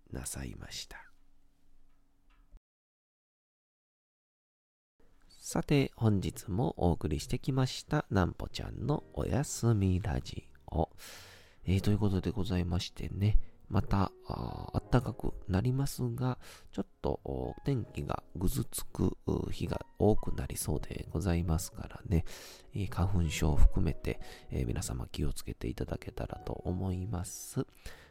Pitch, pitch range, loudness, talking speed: 95 Hz, 80-110 Hz, -34 LUFS, 250 characters per minute